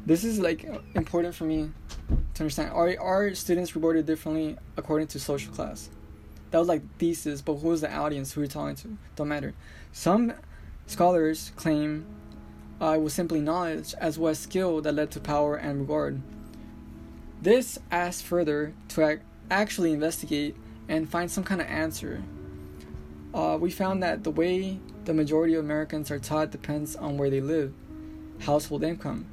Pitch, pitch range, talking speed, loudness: 155 Hz, 145-170 Hz, 165 wpm, -28 LUFS